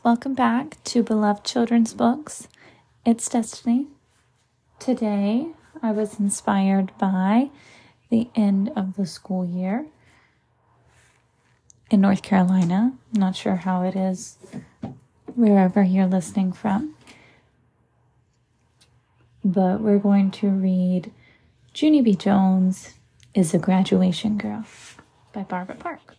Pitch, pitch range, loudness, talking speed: 195 Hz, 180-225 Hz, -22 LUFS, 110 wpm